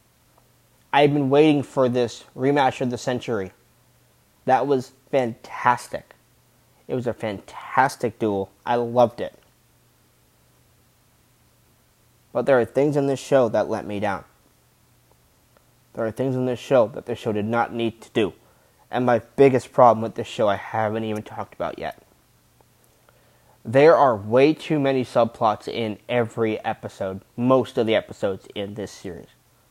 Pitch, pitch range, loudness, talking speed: 120 Hz, 110-130 Hz, -22 LUFS, 150 wpm